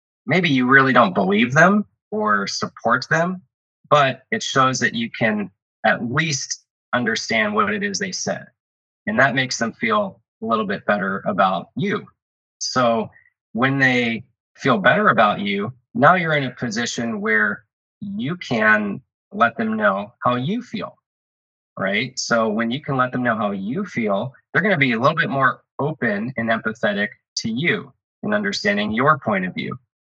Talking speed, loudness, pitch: 170 wpm, -20 LUFS, 135 Hz